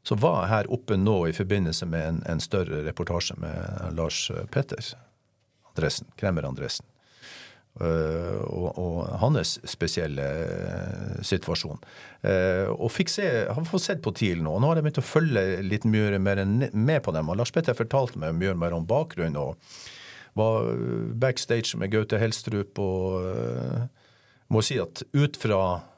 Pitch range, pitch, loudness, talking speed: 90-125 Hz, 110 Hz, -27 LUFS, 125 wpm